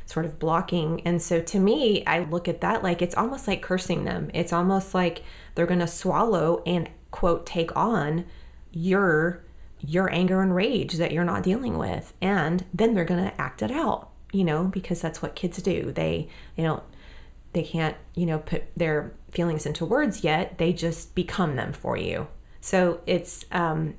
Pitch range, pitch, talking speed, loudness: 165-185 Hz, 170 Hz, 190 wpm, -26 LUFS